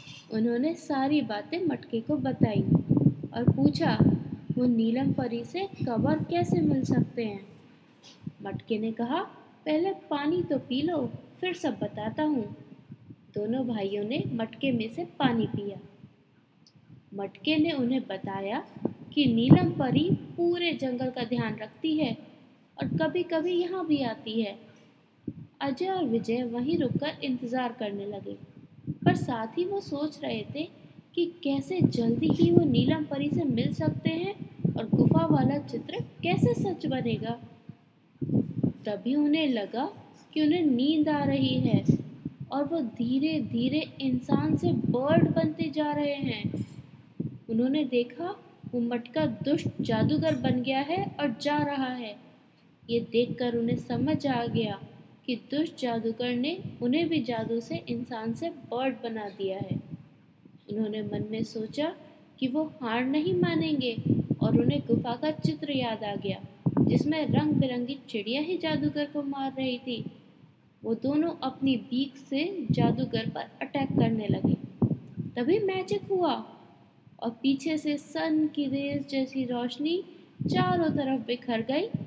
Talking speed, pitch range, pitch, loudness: 145 wpm, 225-305 Hz, 260 Hz, -29 LUFS